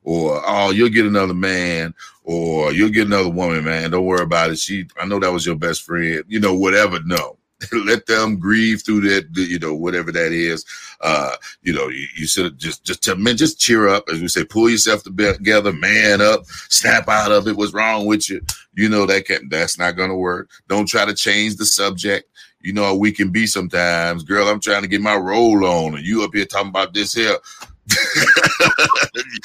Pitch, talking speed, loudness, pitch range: 100 Hz, 210 wpm, -16 LUFS, 90-105 Hz